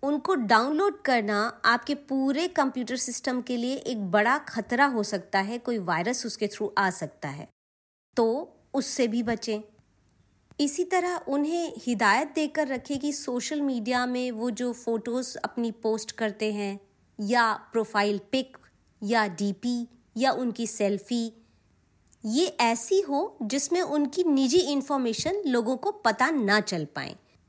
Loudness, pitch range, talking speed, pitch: -27 LUFS, 220-280 Hz, 140 wpm, 245 Hz